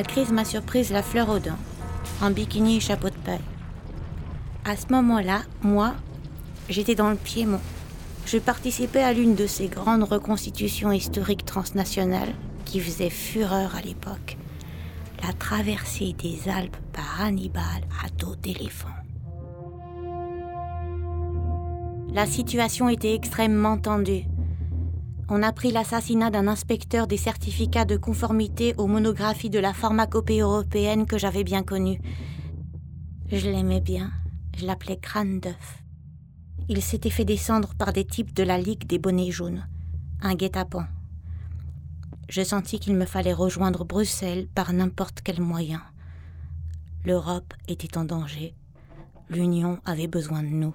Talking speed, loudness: 135 wpm, -26 LUFS